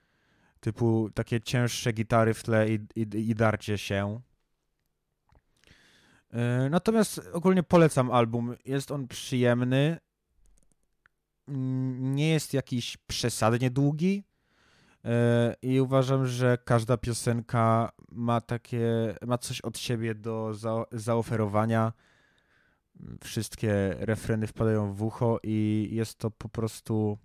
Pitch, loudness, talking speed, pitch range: 115 Hz, -28 LUFS, 105 wpm, 110-125 Hz